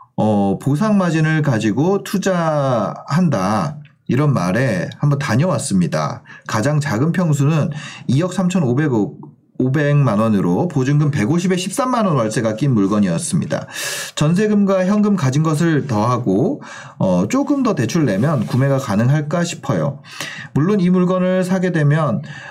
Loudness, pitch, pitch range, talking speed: -17 LUFS, 150 Hz, 140-185 Hz, 255 characters per minute